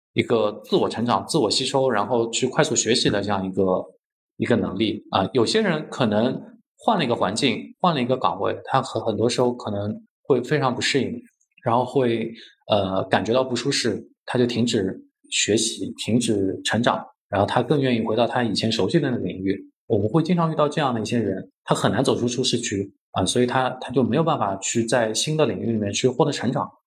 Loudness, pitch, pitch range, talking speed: -22 LUFS, 125 Hz, 110-140 Hz, 315 characters per minute